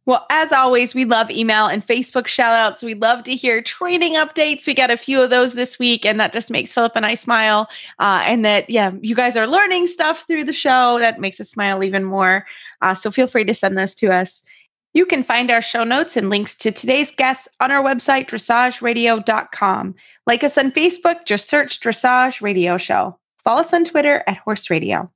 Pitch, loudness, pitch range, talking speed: 235 Hz, -16 LUFS, 215-270 Hz, 215 wpm